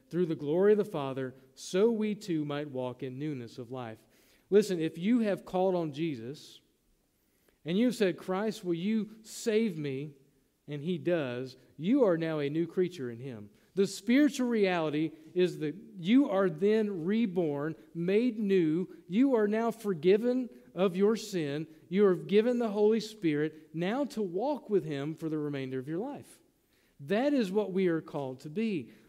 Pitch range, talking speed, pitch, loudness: 150-210 Hz, 175 wpm, 180 Hz, -31 LUFS